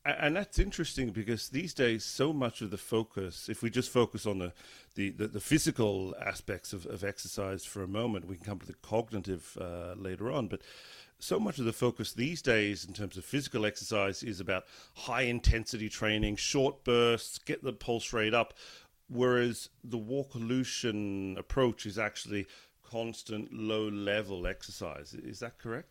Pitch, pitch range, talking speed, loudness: 110 Hz, 100-120 Hz, 165 wpm, -34 LUFS